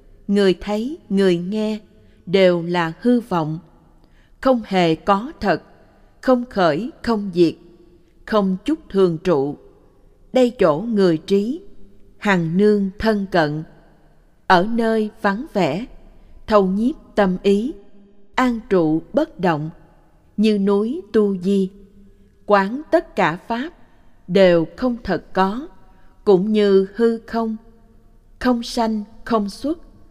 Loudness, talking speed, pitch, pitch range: -19 LUFS, 120 wpm, 200 Hz, 180-230 Hz